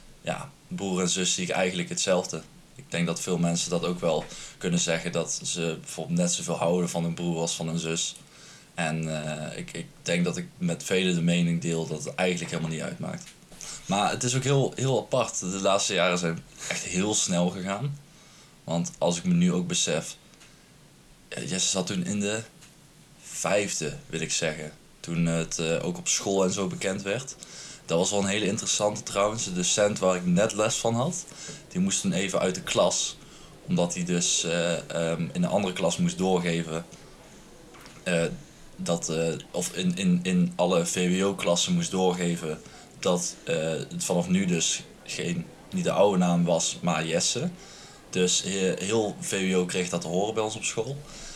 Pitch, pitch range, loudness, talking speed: 95 Hz, 85-135 Hz, -27 LUFS, 190 wpm